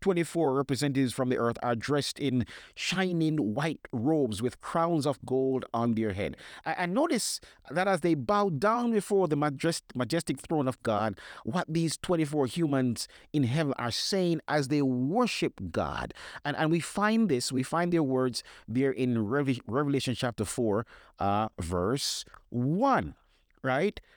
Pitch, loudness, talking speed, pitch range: 145 Hz, -29 LUFS, 155 wpm, 125-165 Hz